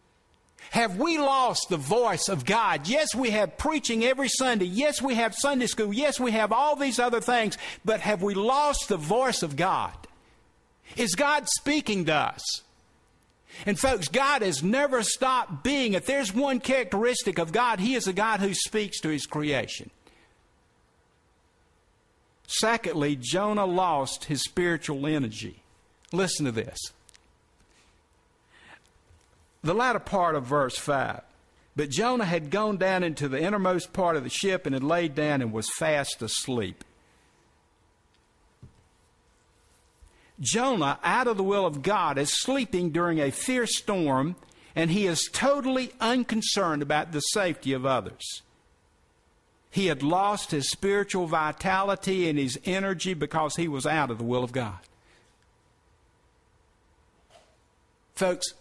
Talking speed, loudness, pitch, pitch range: 140 wpm, -26 LUFS, 180 Hz, 140-225 Hz